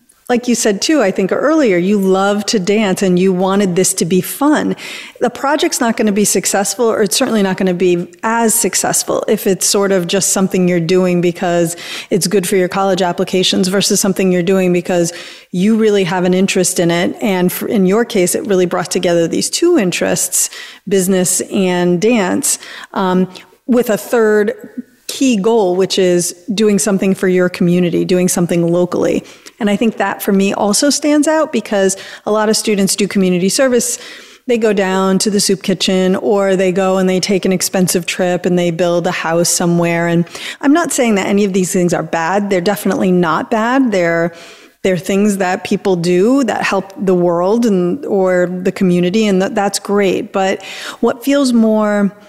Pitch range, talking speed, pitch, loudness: 185-215 Hz, 195 wpm, 195 Hz, -13 LUFS